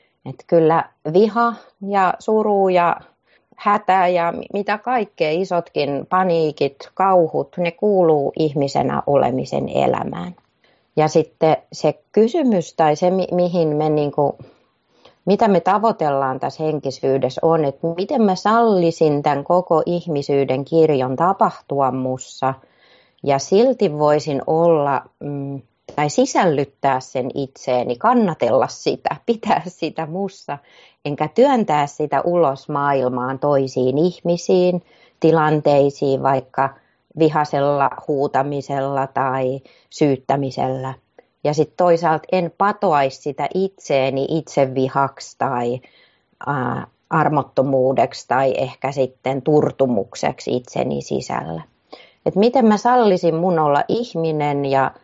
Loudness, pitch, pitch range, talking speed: -19 LUFS, 150 Hz, 135-180 Hz, 105 wpm